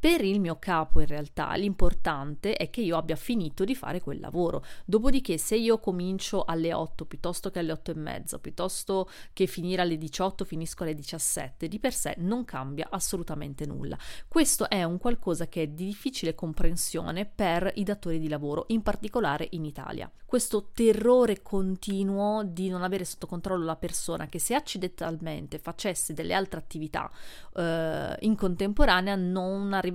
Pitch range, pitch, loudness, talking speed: 160-200 Hz, 180 Hz, -30 LUFS, 165 wpm